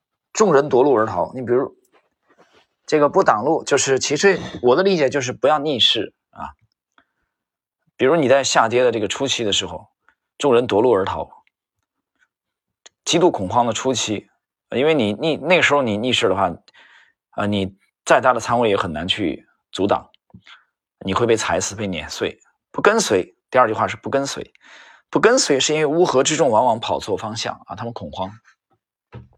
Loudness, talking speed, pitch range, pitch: -18 LUFS, 250 characters per minute, 100-145 Hz, 125 Hz